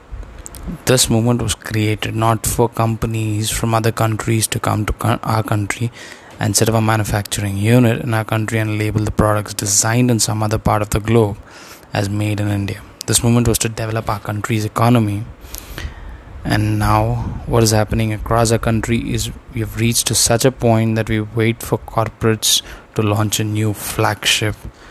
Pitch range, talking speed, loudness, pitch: 105-115 Hz, 180 wpm, -17 LUFS, 110 Hz